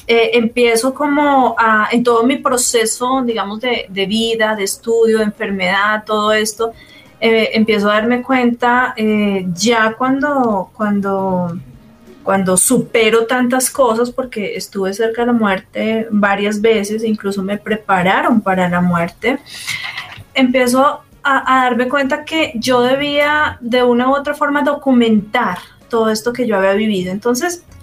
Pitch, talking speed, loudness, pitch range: 230 Hz, 140 wpm, -15 LUFS, 210-255 Hz